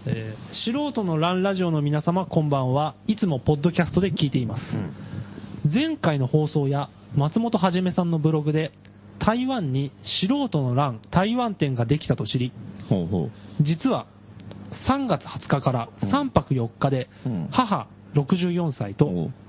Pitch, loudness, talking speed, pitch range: 150 Hz, -24 LUFS, 250 characters per minute, 130-185 Hz